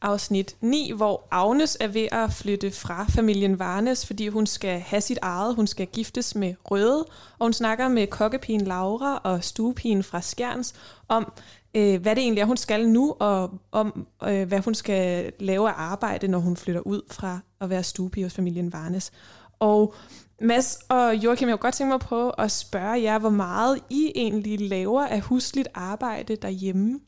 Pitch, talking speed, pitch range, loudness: 215 Hz, 180 wpm, 195-235 Hz, -25 LUFS